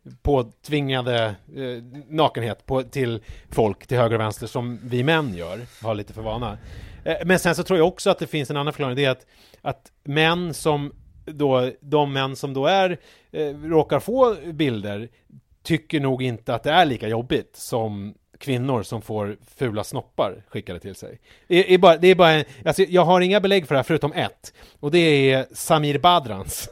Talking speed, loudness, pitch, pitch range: 190 wpm, -21 LUFS, 135 Hz, 115-160 Hz